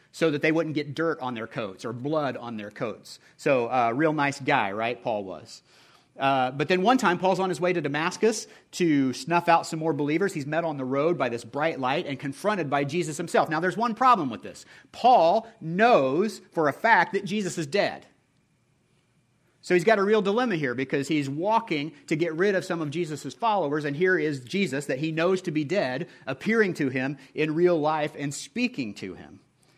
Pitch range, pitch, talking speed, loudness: 140-185 Hz, 160 Hz, 215 wpm, -25 LUFS